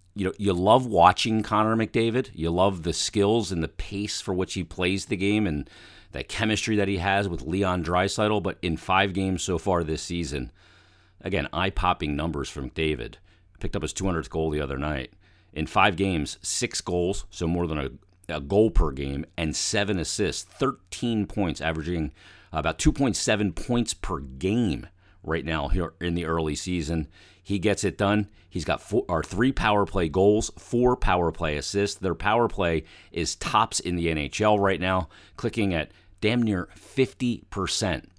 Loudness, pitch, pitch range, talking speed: -26 LUFS, 95 Hz, 85-100 Hz, 175 wpm